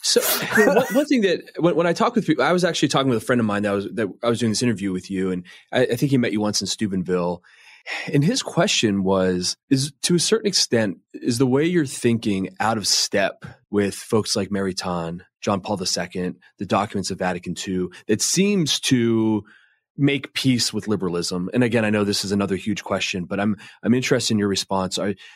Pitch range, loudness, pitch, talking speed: 95-135 Hz, -21 LUFS, 105 Hz, 220 wpm